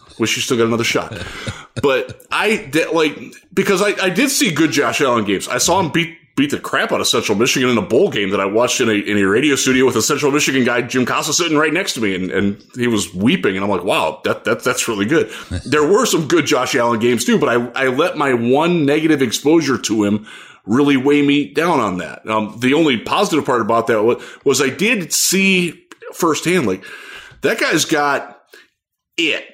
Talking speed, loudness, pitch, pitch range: 225 wpm, -16 LUFS, 140 Hz, 115-180 Hz